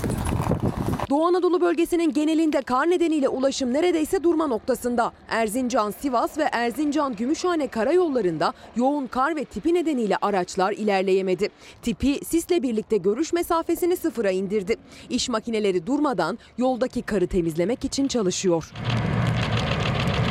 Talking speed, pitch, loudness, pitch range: 110 wpm, 255 Hz, -23 LUFS, 215-320 Hz